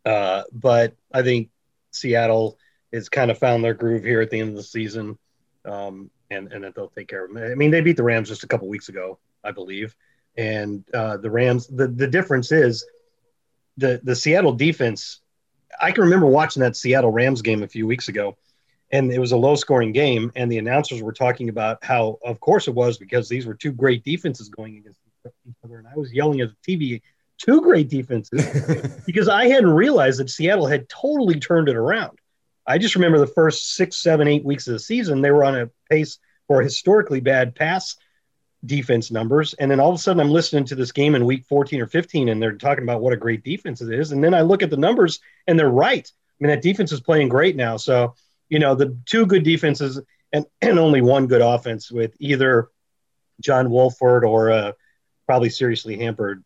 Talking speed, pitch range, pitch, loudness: 215 wpm, 115-150 Hz, 130 Hz, -19 LUFS